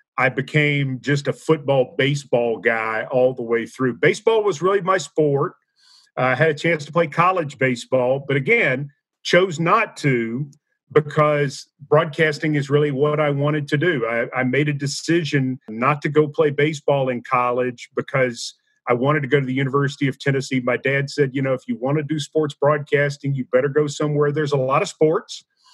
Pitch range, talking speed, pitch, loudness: 130-155 Hz, 190 wpm, 145 Hz, -20 LUFS